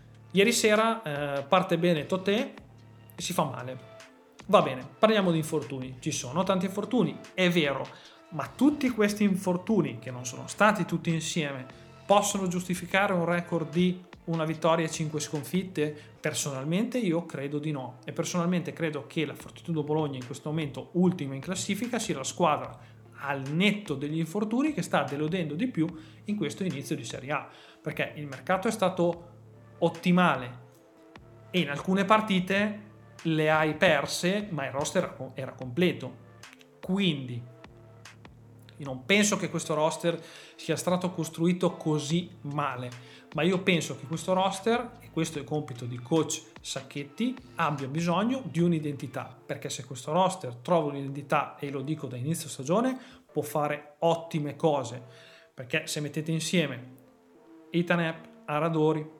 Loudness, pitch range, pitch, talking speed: -29 LUFS, 140-180 Hz, 160 Hz, 150 wpm